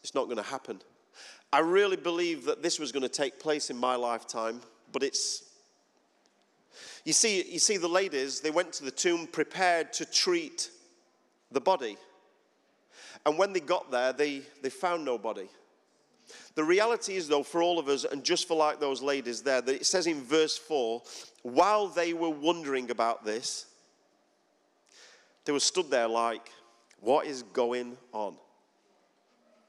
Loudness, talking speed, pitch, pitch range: -29 LUFS, 165 wpm, 155 Hz, 125-185 Hz